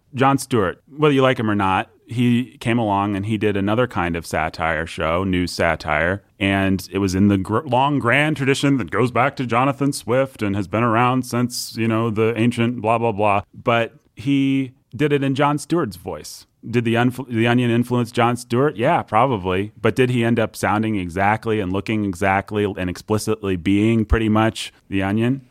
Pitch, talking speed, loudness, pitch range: 115 Hz, 195 wpm, -20 LUFS, 100-125 Hz